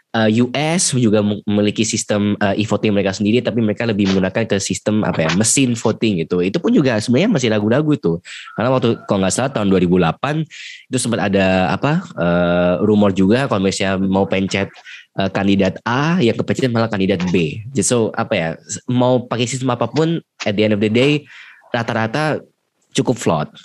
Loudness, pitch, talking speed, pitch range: -17 LUFS, 105 Hz, 170 wpm, 100-120 Hz